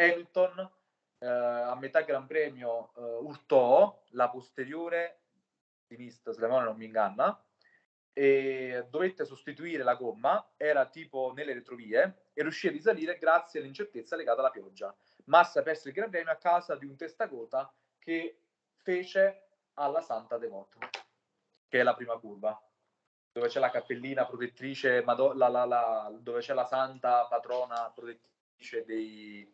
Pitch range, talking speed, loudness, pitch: 120-165 Hz, 145 wpm, -31 LUFS, 135 Hz